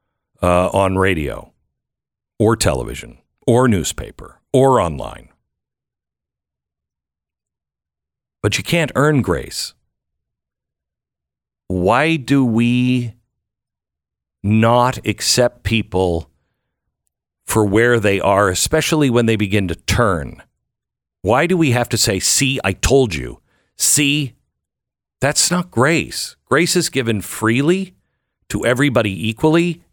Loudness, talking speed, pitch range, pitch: -16 LUFS, 100 wpm, 90-135 Hz, 110 Hz